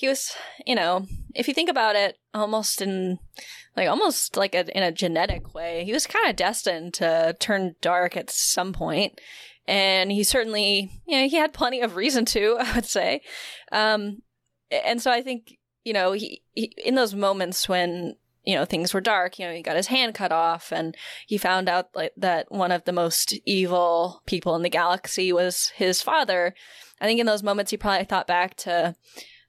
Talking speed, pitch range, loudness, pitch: 200 wpm, 180-225 Hz, -24 LUFS, 195 Hz